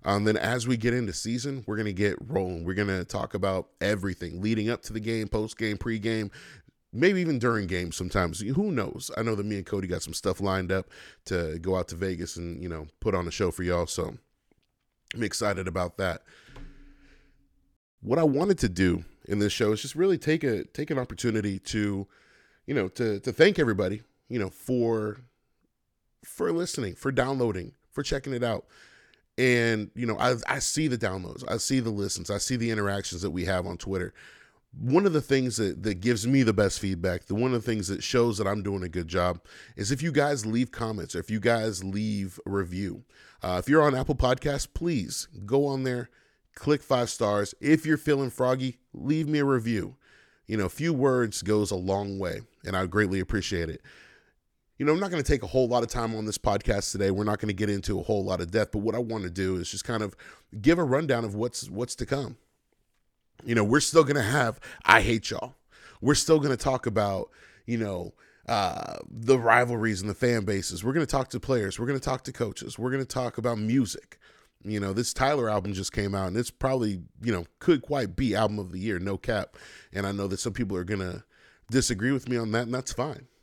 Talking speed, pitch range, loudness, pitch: 225 wpm, 95-130 Hz, -28 LUFS, 110 Hz